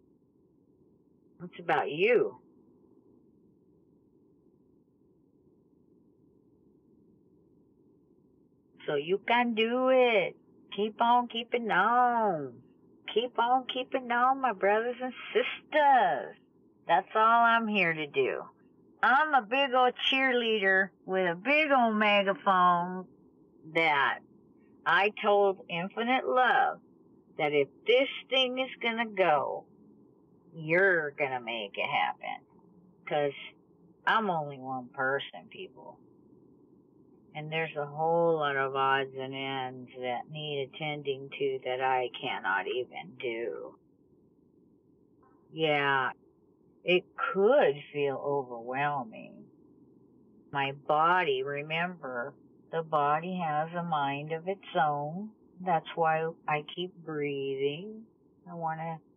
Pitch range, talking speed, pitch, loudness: 145-240 Hz, 100 wpm, 180 Hz, -29 LUFS